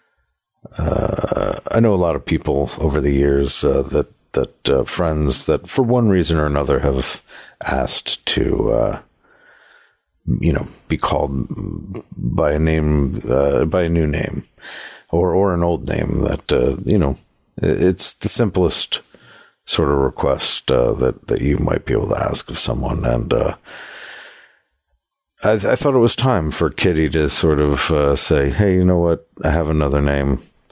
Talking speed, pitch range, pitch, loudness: 170 wpm, 70-90 Hz, 80 Hz, -17 LUFS